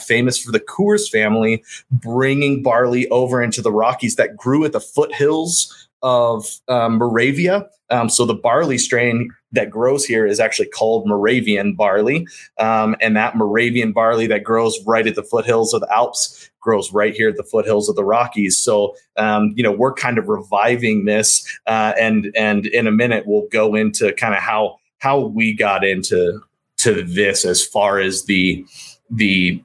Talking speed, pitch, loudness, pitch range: 175 wpm, 115 Hz, -16 LUFS, 110-130 Hz